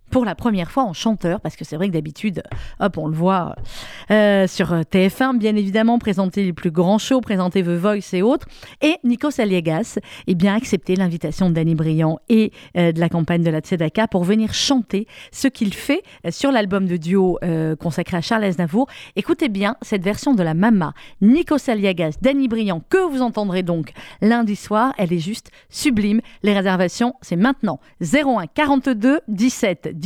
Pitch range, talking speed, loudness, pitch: 175-235 Hz, 190 wpm, -19 LUFS, 200 Hz